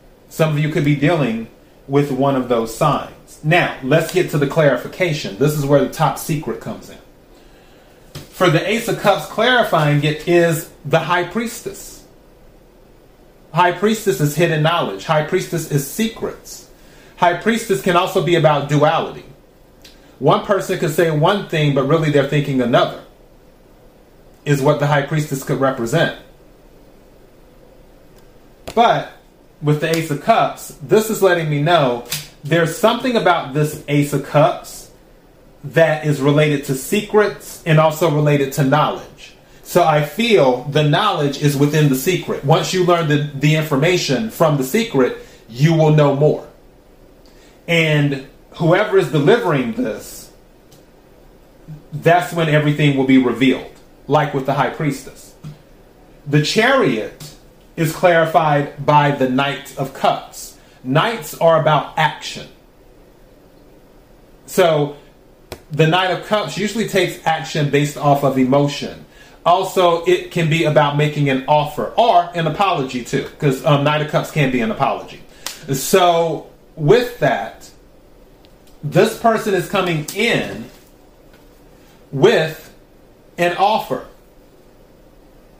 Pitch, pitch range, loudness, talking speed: 155 Hz, 145-175 Hz, -16 LUFS, 135 wpm